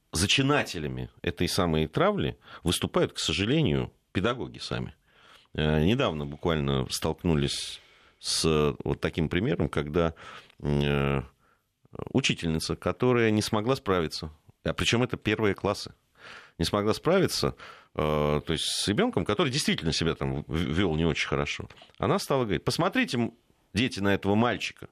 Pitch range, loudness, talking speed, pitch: 75-105 Hz, -27 LUFS, 120 wpm, 85 Hz